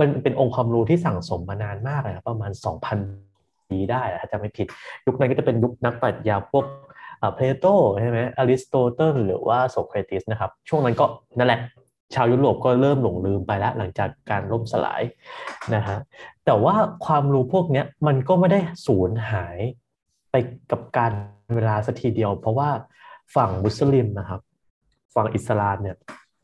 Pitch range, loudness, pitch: 105-135 Hz, -22 LUFS, 115 Hz